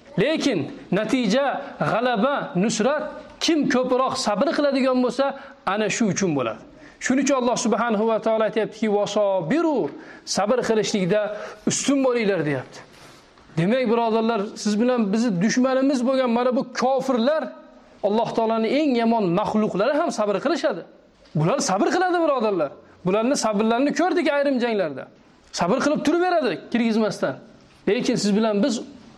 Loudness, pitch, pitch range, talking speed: -22 LUFS, 245 Hz, 215-280 Hz, 130 wpm